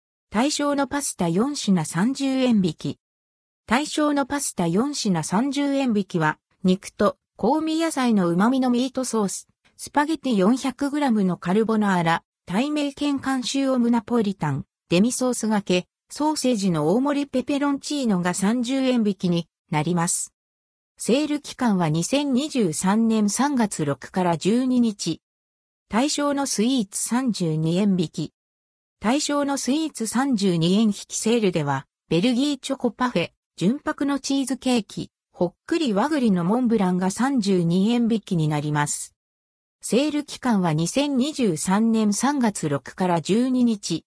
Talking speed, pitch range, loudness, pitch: 245 characters per minute, 175-265 Hz, -23 LUFS, 220 Hz